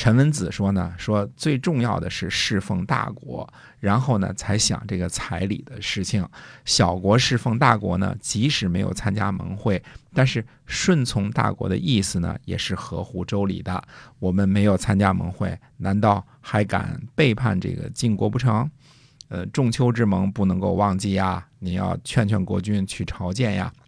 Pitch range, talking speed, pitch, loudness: 95-125 Hz, 250 characters per minute, 105 Hz, -23 LUFS